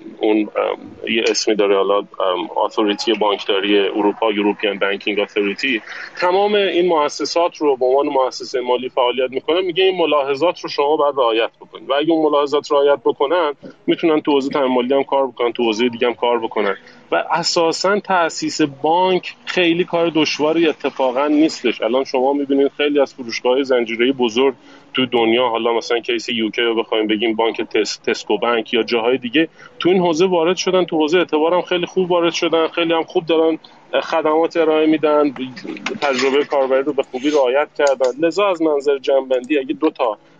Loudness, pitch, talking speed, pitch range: -17 LUFS, 145 Hz, 170 wpm, 125-165 Hz